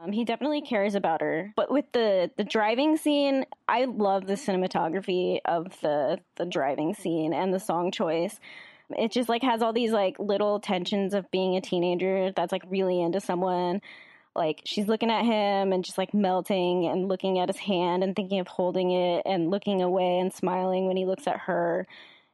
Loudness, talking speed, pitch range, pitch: -27 LUFS, 190 wpm, 180-210 Hz, 190 Hz